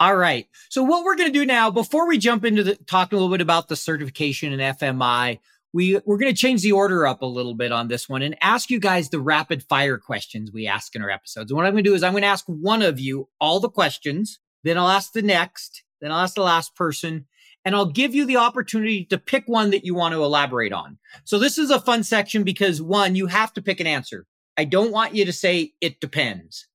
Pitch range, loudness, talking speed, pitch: 150-220 Hz, -21 LUFS, 255 wpm, 185 Hz